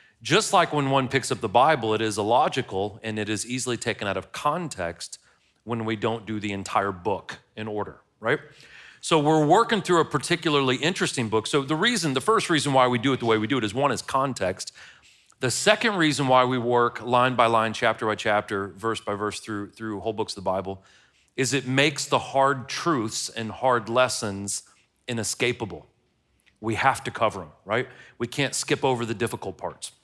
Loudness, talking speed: -24 LUFS, 200 wpm